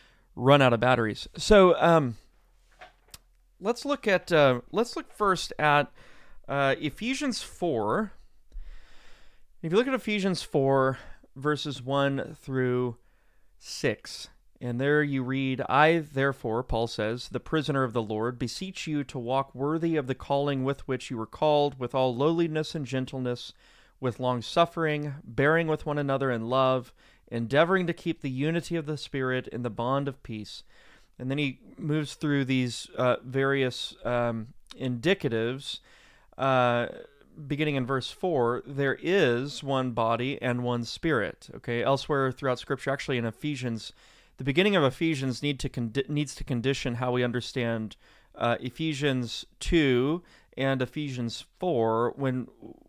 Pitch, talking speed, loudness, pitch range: 135 Hz, 145 wpm, -28 LUFS, 125-150 Hz